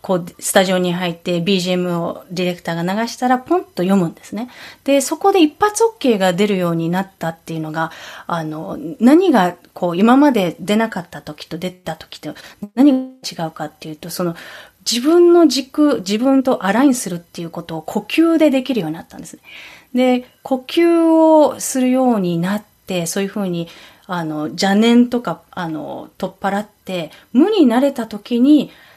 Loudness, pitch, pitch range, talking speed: -16 LUFS, 200 Hz, 175-260 Hz, 340 characters per minute